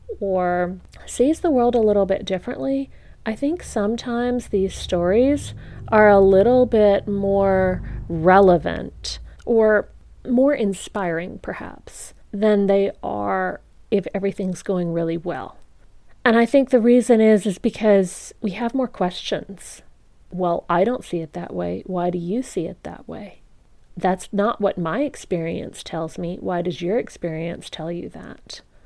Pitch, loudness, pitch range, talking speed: 195 Hz, -20 LUFS, 180-235 Hz, 150 wpm